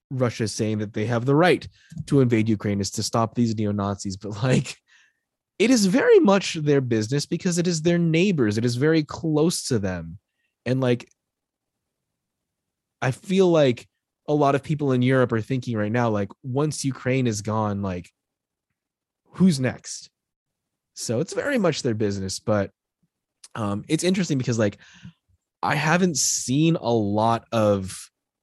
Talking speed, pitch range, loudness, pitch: 165 wpm, 105-150 Hz, -23 LUFS, 125 Hz